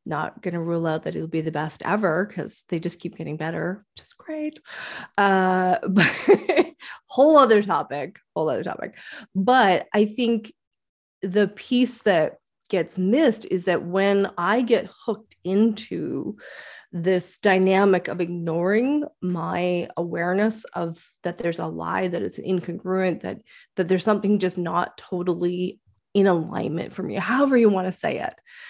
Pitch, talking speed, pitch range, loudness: 185 Hz, 155 wpm, 175-215 Hz, -23 LUFS